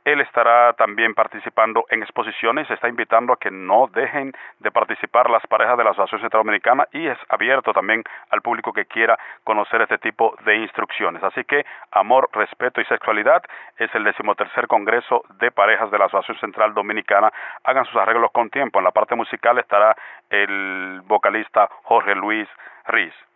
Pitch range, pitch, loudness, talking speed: 100-120 Hz, 110 Hz, -19 LUFS, 170 wpm